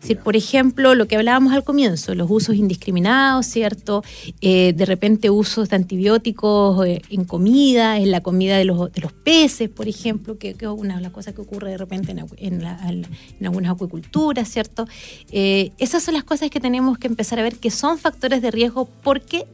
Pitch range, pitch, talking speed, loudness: 190-250 Hz, 215 Hz, 200 wpm, -18 LUFS